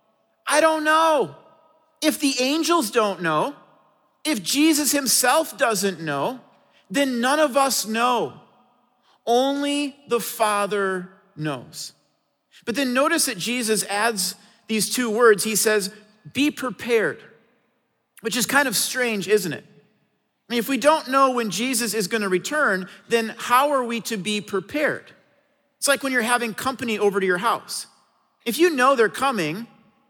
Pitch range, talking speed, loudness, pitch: 215-280 Hz, 150 wpm, -21 LUFS, 245 Hz